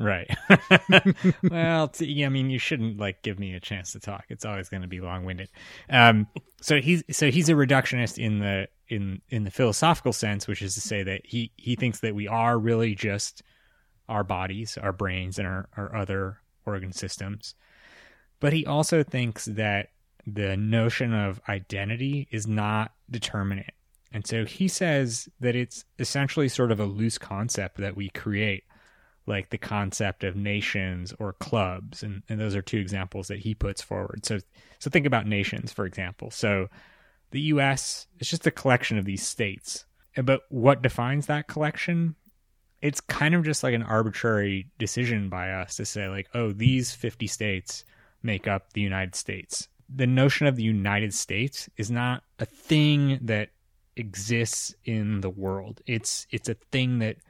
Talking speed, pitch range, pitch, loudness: 175 wpm, 100-130 Hz, 110 Hz, -26 LUFS